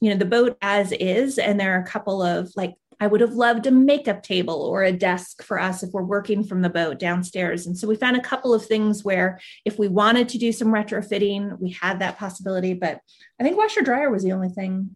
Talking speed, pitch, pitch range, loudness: 245 wpm, 200 Hz, 185-220 Hz, -22 LUFS